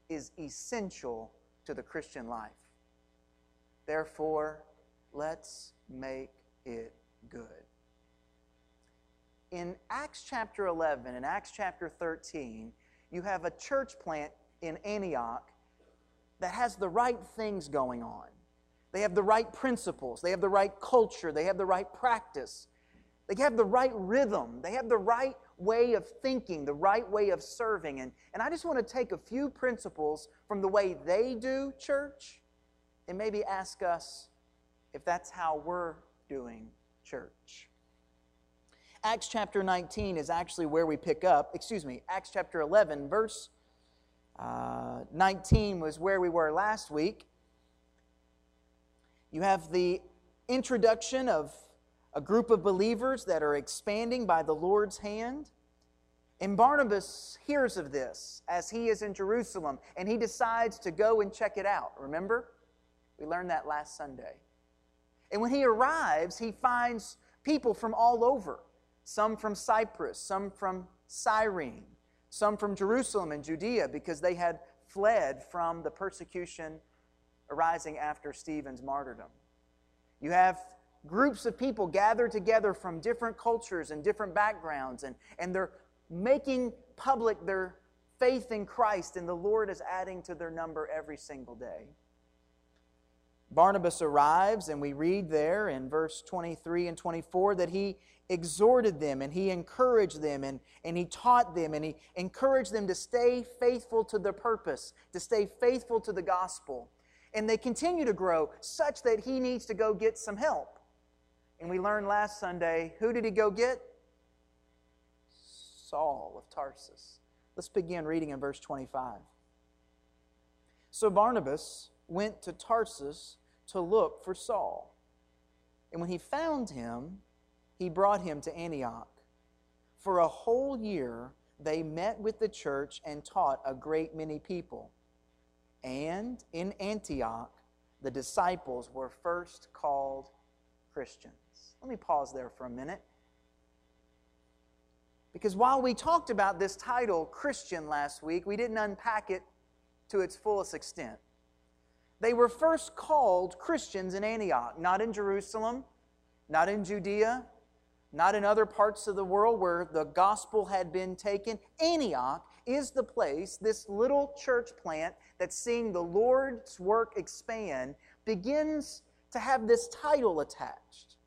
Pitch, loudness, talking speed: 175 Hz, -32 LUFS, 140 wpm